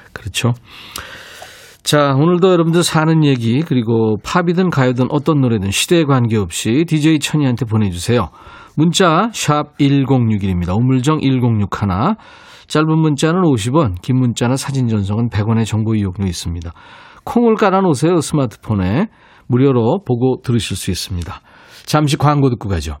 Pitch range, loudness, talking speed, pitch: 110-155 Hz, -15 LUFS, 305 characters per minute, 130 Hz